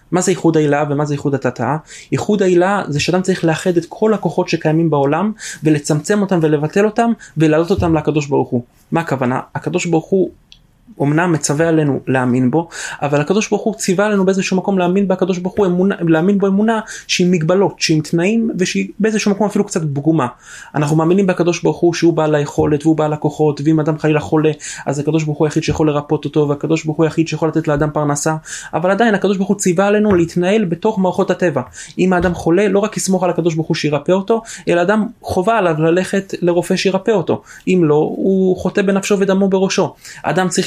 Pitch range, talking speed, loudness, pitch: 155-195 Hz, 175 wpm, -16 LUFS, 175 Hz